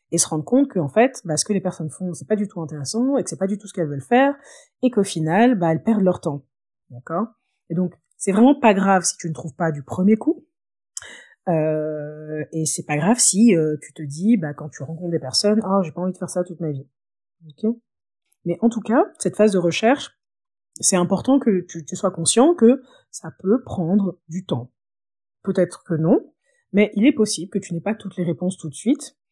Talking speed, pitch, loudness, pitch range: 235 wpm, 185 Hz, -20 LUFS, 160-220 Hz